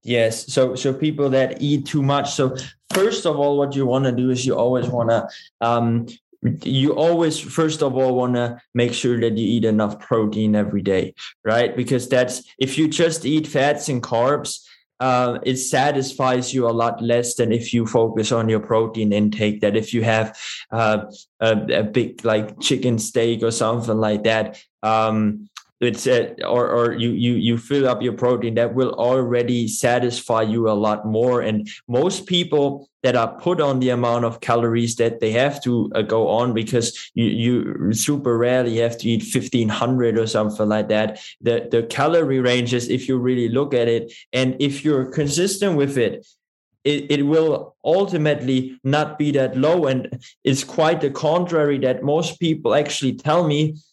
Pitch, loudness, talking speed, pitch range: 125 Hz, -20 LUFS, 185 wpm, 115-140 Hz